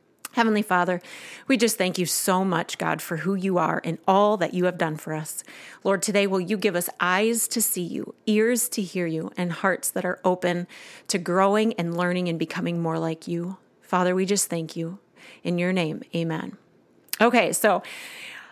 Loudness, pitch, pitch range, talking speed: -24 LUFS, 180 Hz, 170-200 Hz, 195 wpm